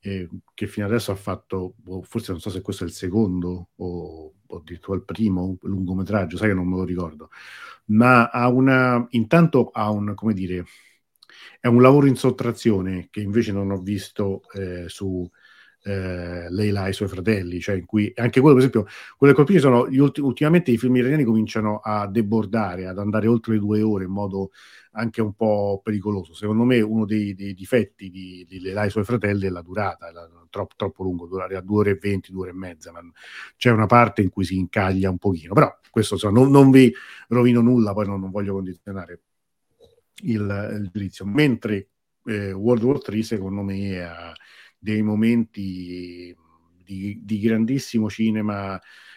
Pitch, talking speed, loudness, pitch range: 105 Hz, 185 wpm, -21 LUFS, 95-115 Hz